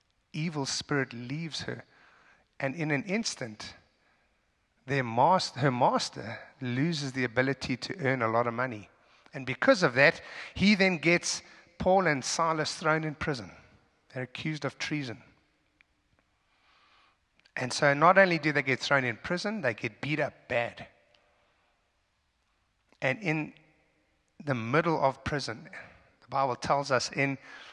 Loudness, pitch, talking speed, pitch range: -28 LUFS, 140 Hz, 140 wpm, 125-155 Hz